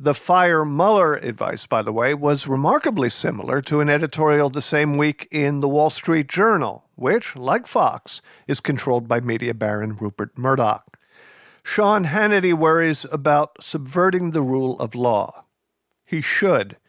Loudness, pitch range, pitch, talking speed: -20 LUFS, 135-165 Hz, 150 Hz, 150 wpm